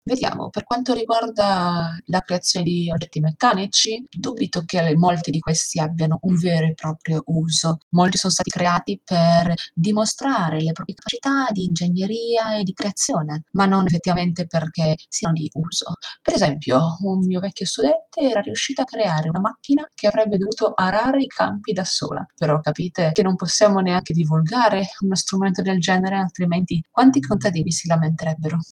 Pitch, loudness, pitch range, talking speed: 180 Hz, -20 LUFS, 165-210 Hz, 160 wpm